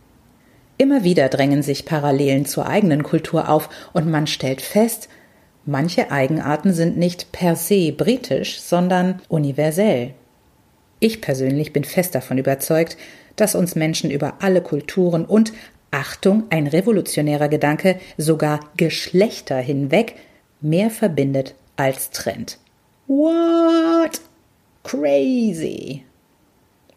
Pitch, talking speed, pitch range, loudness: 160 Hz, 105 wpm, 140-195 Hz, -19 LUFS